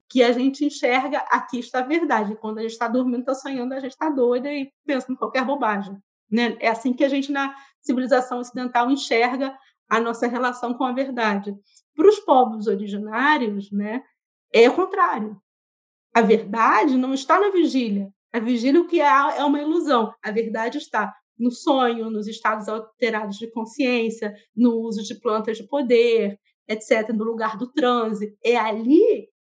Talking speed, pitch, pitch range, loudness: 175 wpm, 245 Hz, 220-275 Hz, -22 LUFS